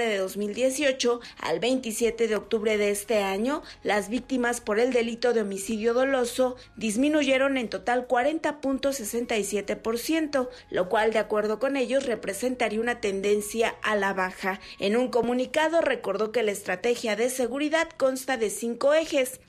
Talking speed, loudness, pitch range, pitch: 140 wpm, -26 LUFS, 215-260 Hz, 240 Hz